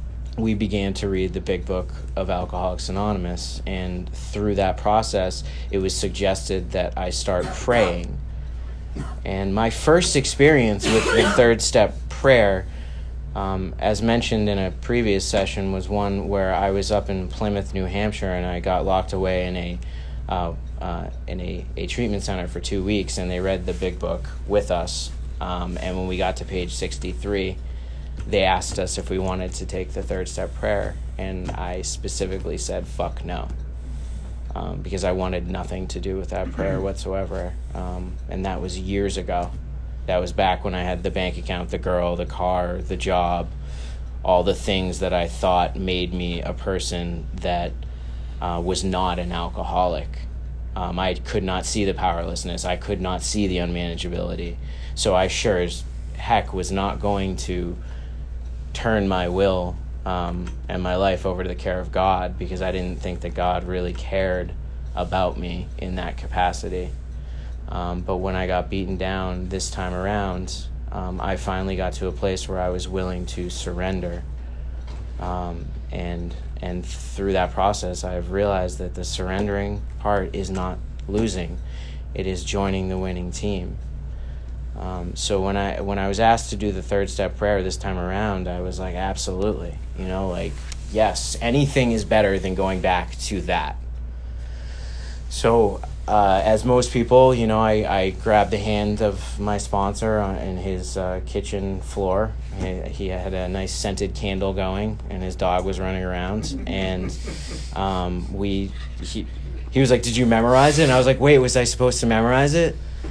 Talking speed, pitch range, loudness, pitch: 175 wpm, 75-95 Hz, -23 LUFS, 90 Hz